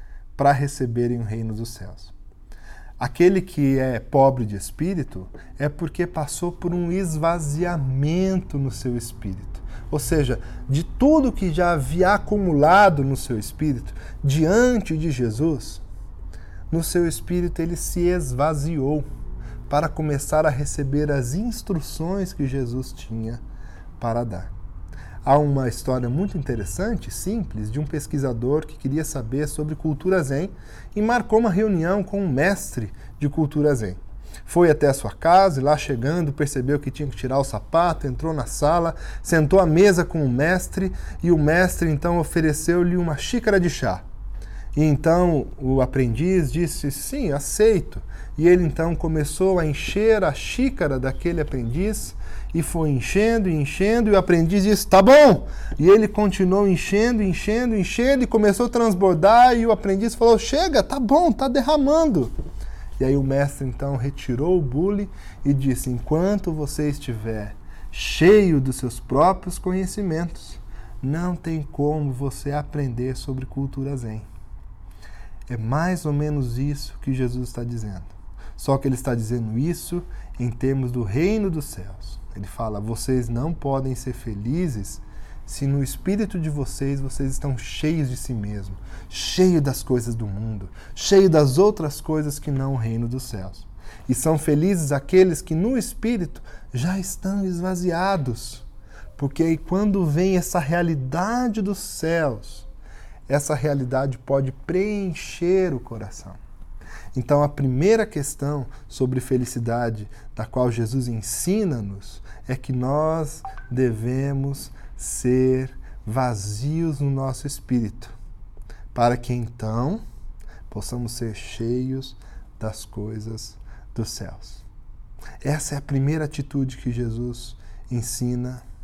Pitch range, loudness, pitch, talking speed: 115-170 Hz, -22 LUFS, 140 Hz, 140 wpm